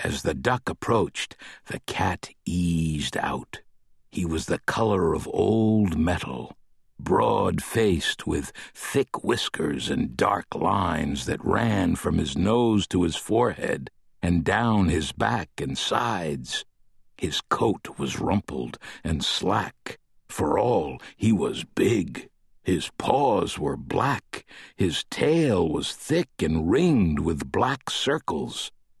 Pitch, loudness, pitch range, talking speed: 85 Hz, -25 LUFS, 80-105 Hz, 125 wpm